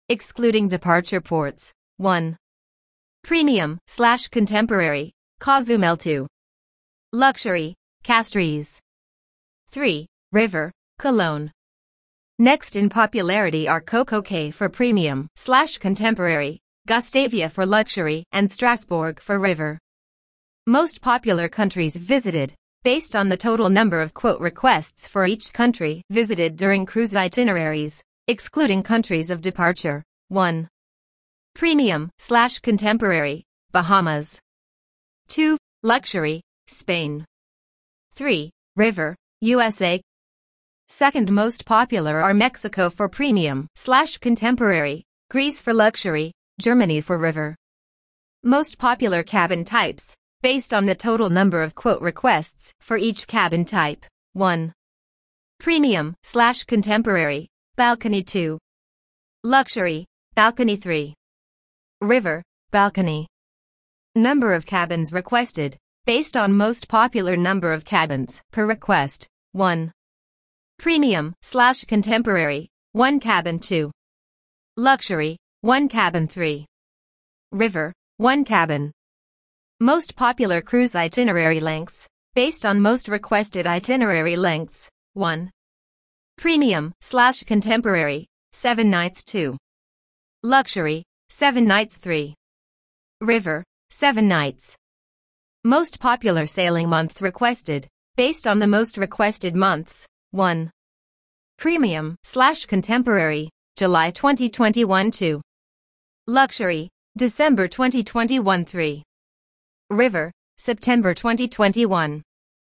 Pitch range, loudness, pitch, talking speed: 165-235 Hz, -20 LUFS, 200 Hz, 95 wpm